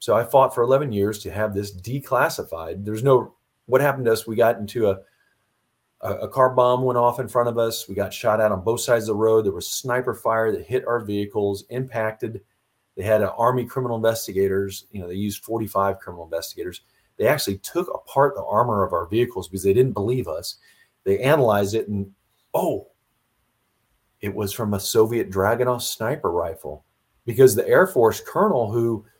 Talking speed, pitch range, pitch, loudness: 195 wpm, 100-120 Hz, 110 Hz, -22 LUFS